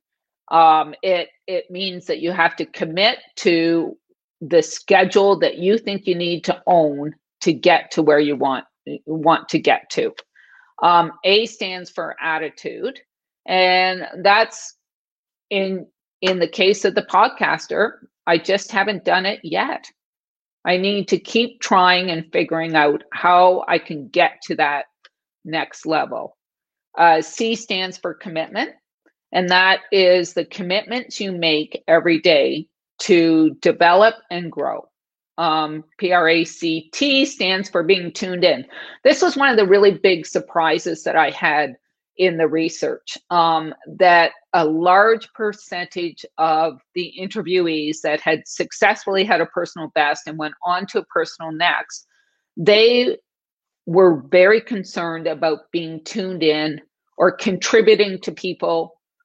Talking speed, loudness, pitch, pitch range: 140 wpm, -18 LUFS, 180 Hz, 165-205 Hz